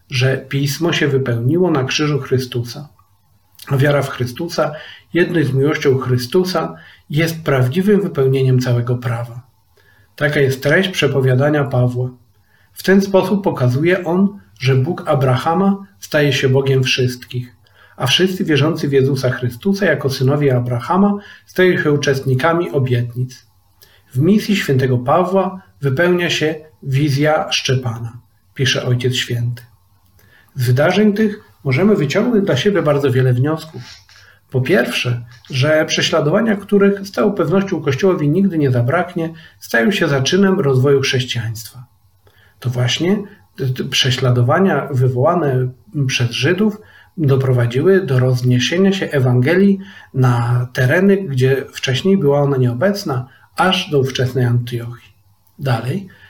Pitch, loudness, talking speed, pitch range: 135 Hz, -16 LUFS, 120 wpm, 125-170 Hz